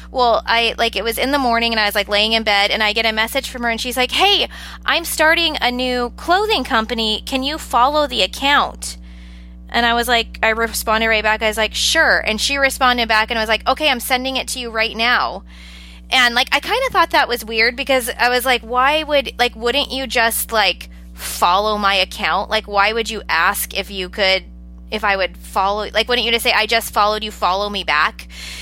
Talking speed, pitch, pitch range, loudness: 235 wpm, 230 Hz, 205-255 Hz, -16 LUFS